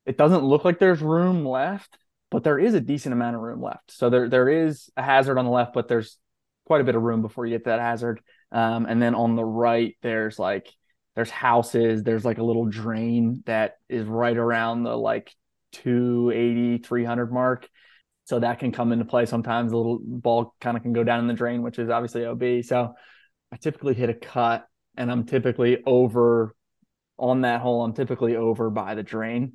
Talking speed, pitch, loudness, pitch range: 210 wpm, 120 Hz, -23 LUFS, 115-125 Hz